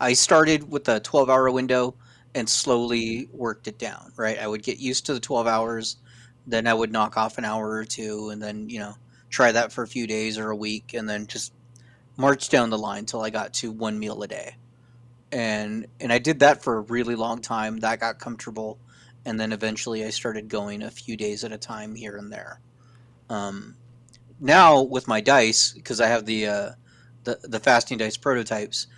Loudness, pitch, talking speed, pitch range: -23 LUFS, 115 Hz, 205 wpm, 110-125 Hz